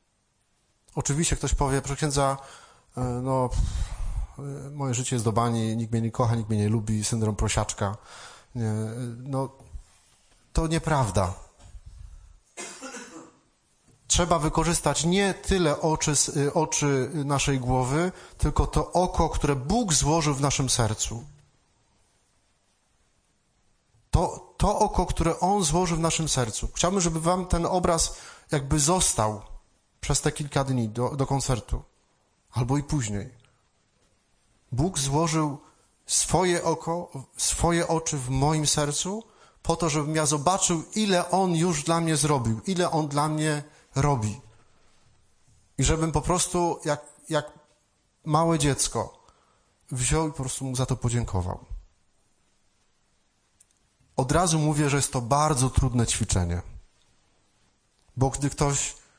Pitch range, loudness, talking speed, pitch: 110-155 Hz, -25 LUFS, 125 wpm, 135 Hz